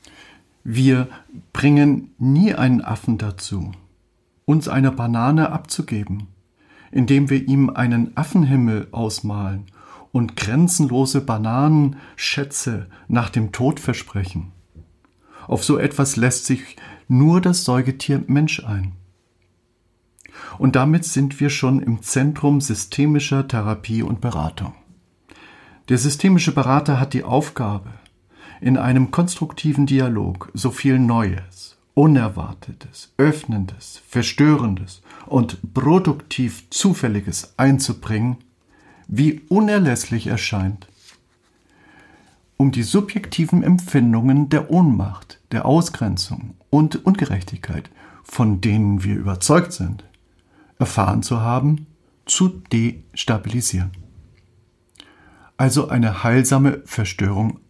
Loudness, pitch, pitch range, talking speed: -19 LUFS, 125 Hz, 100-140 Hz, 95 wpm